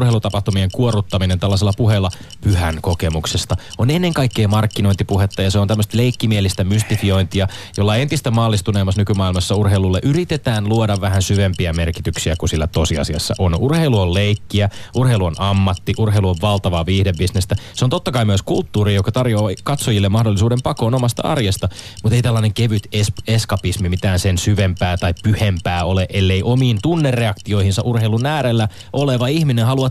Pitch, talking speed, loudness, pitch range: 105 Hz, 145 wpm, -17 LUFS, 95-115 Hz